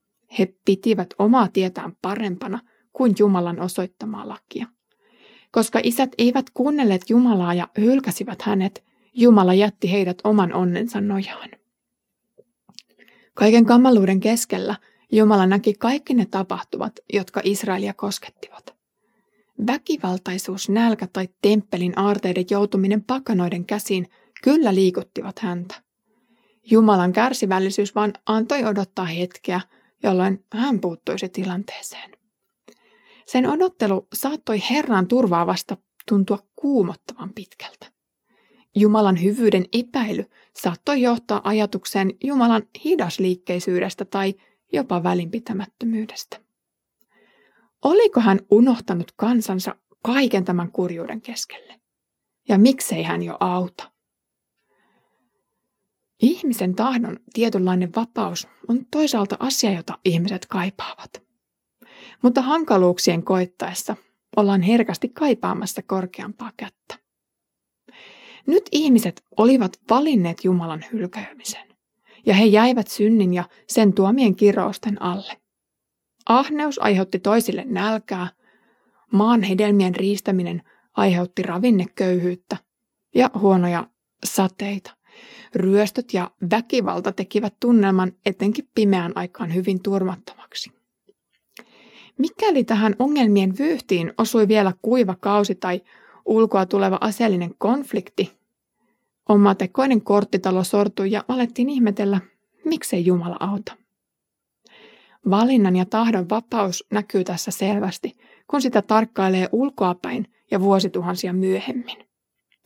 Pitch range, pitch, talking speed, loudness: 190-235 Hz, 205 Hz, 95 wpm, -20 LUFS